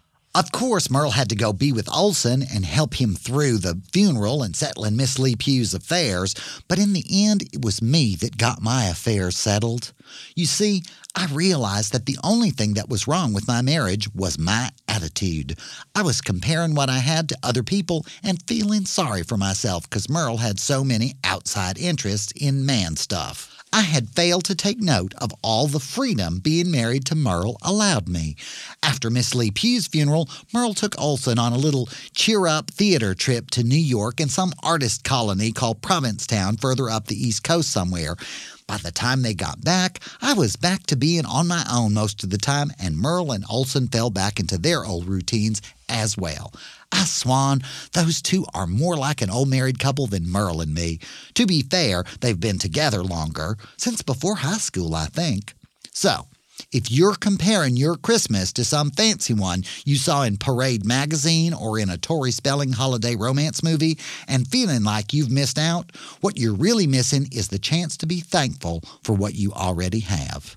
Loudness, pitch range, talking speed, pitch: -22 LUFS, 105-160 Hz, 190 wpm, 130 Hz